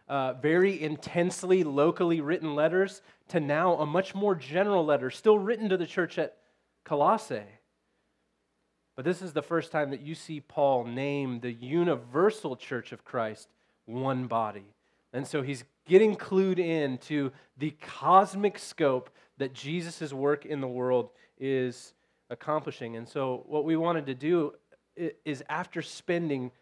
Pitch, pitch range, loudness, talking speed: 150 Hz, 130-175 Hz, -29 LUFS, 150 wpm